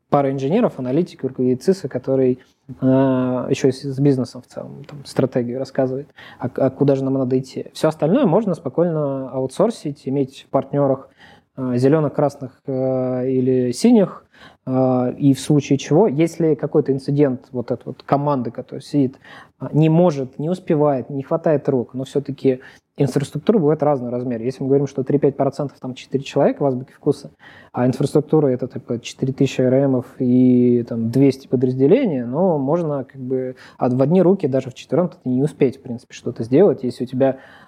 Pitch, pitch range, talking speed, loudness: 135 Hz, 130-145 Hz, 165 wpm, -19 LUFS